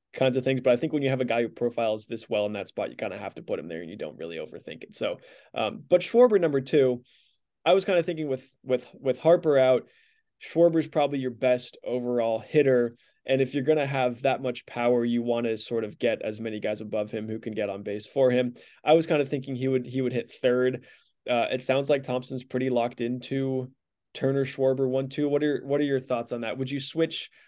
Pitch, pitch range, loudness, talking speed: 130 Hz, 120-140 Hz, -26 LUFS, 250 wpm